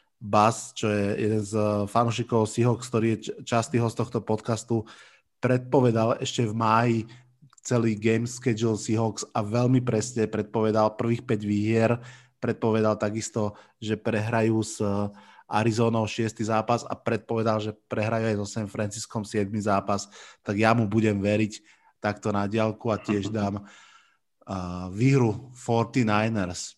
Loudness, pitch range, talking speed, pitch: -26 LUFS, 105-115 Hz, 135 wpm, 110 Hz